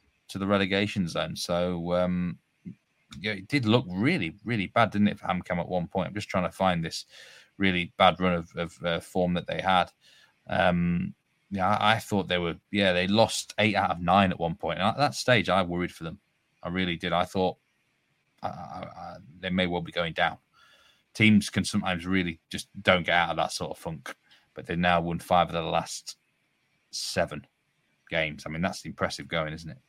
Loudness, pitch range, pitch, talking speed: -27 LUFS, 85-100 Hz, 90 Hz, 210 wpm